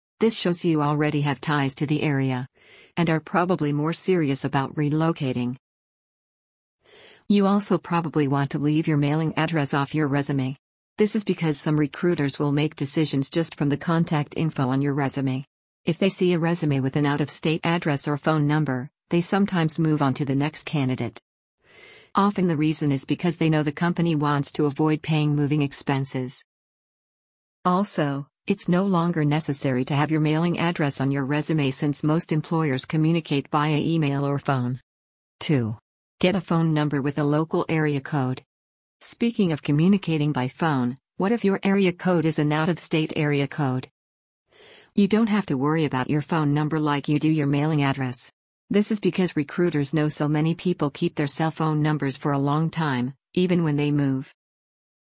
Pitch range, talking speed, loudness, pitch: 140-165 Hz, 180 wpm, -23 LUFS, 150 Hz